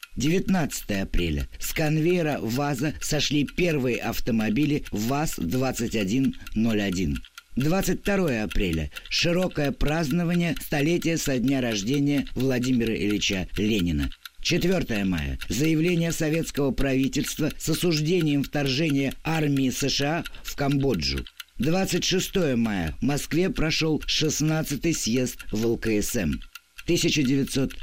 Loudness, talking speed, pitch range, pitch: -25 LUFS, 90 wpm, 110-160 Hz, 140 Hz